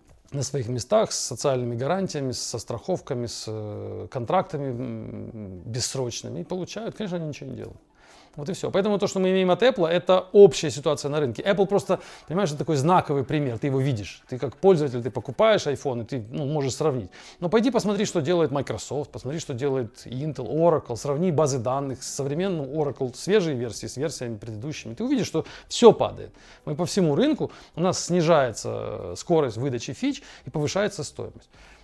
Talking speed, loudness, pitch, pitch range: 175 wpm, -25 LUFS, 150 Hz, 125-185 Hz